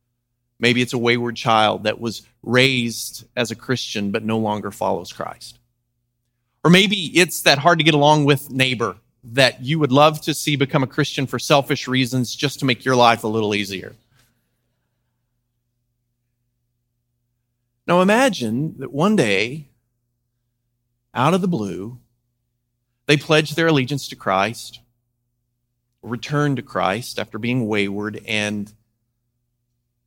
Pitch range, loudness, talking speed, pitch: 120-135 Hz, -19 LUFS, 135 wpm, 120 Hz